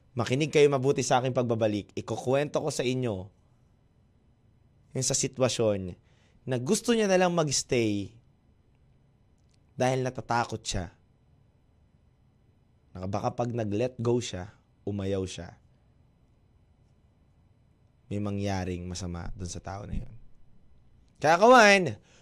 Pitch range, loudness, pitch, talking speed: 100-130 Hz, -27 LUFS, 120 Hz, 105 wpm